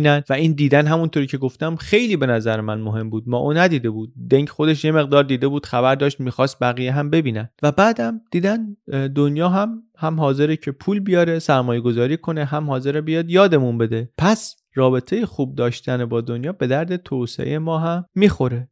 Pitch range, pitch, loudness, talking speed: 125-165 Hz, 145 Hz, -19 LUFS, 185 wpm